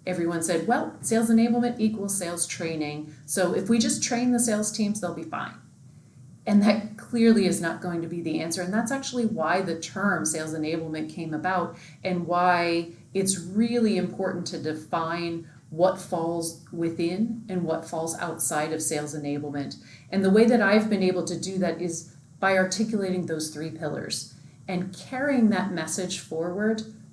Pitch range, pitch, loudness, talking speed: 160-205 Hz, 175 Hz, -26 LUFS, 170 wpm